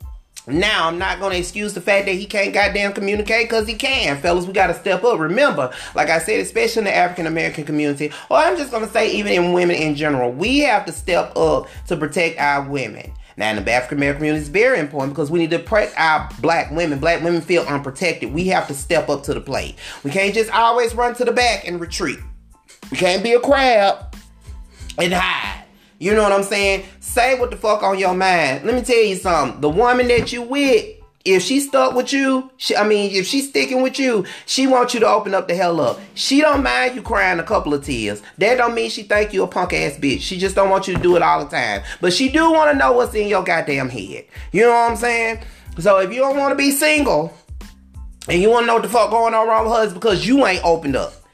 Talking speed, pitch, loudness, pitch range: 250 wpm, 200 Hz, -17 LUFS, 170-240 Hz